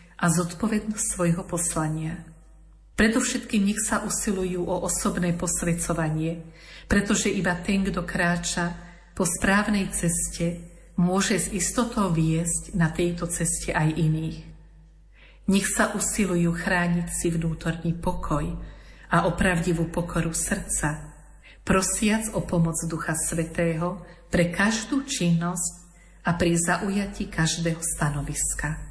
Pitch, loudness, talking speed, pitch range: 175 Hz, -25 LUFS, 110 wpm, 165-195 Hz